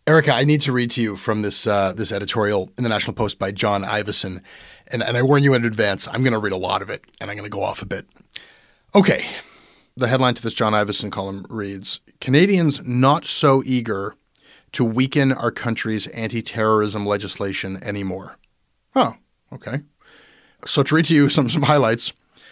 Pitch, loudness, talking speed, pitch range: 115 Hz, -20 LUFS, 195 wpm, 105-135 Hz